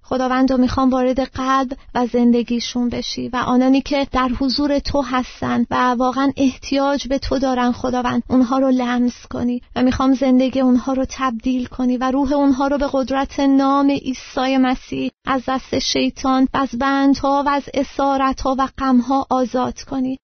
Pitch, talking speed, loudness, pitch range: 260 Hz, 160 wpm, -18 LUFS, 250-275 Hz